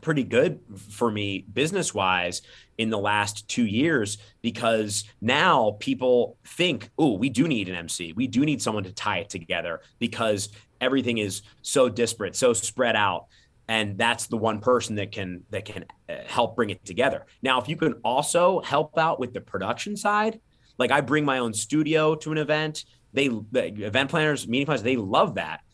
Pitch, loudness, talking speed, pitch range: 120 Hz, -25 LUFS, 180 wpm, 105-150 Hz